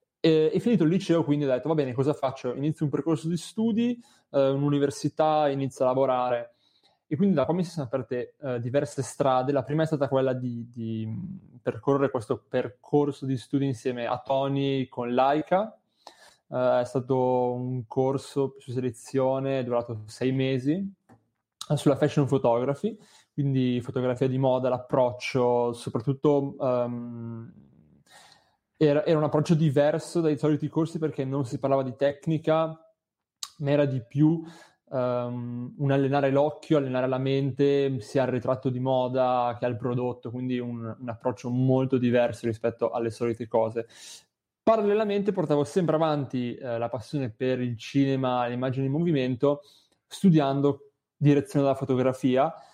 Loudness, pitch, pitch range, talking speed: -26 LUFS, 135 Hz, 125-150 Hz, 150 wpm